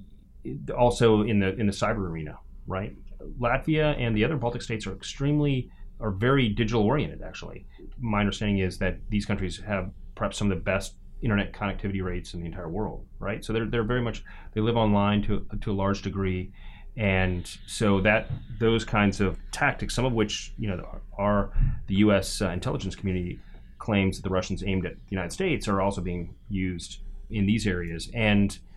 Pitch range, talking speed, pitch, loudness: 95-115 Hz, 185 wpm, 100 Hz, -27 LUFS